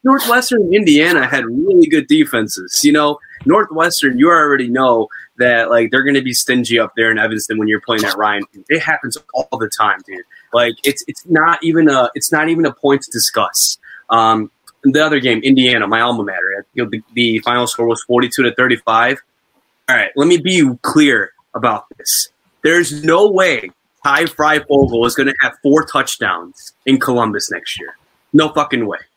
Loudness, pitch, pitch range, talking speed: -13 LUFS, 135 Hz, 115-160 Hz, 190 wpm